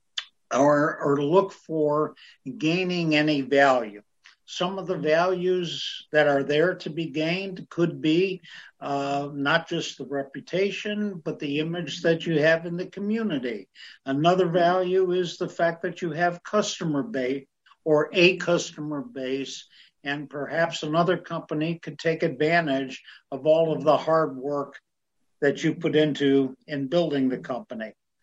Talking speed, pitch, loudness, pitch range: 145 wpm, 160 Hz, -25 LUFS, 145-175 Hz